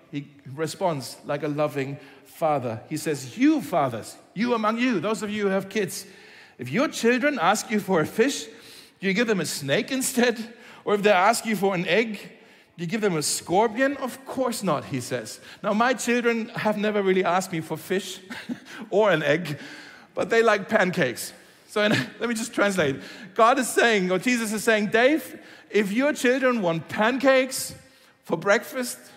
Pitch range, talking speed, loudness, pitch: 175-240 Hz, 185 wpm, -24 LUFS, 210 Hz